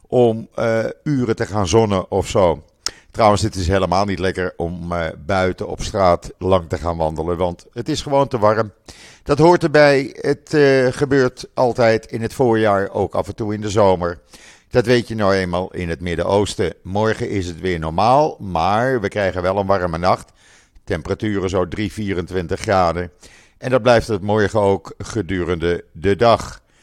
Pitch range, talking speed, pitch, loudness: 90-115 Hz, 175 wpm, 100 Hz, -18 LUFS